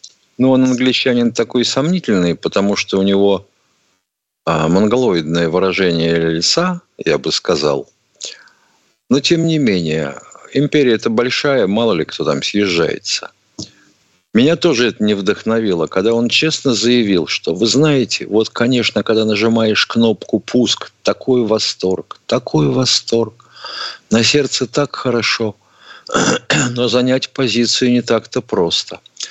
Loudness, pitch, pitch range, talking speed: -15 LUFS, 115 Hz, 100-130 Hz, 125 wpm